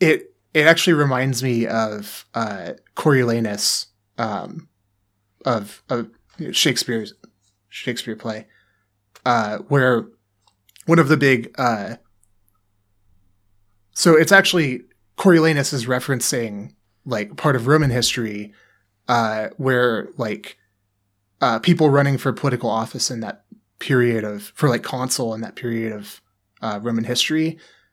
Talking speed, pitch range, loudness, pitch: 120 wpm, 105-135 Hz, -19 LUFS, 115 Hz